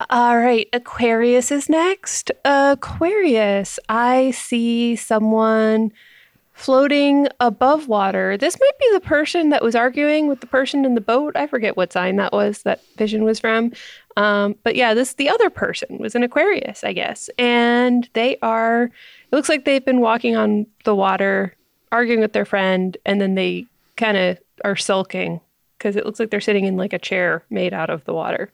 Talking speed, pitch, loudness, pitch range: 180 wpm, 235 Hz, -18 LUFS, 205-265 Hz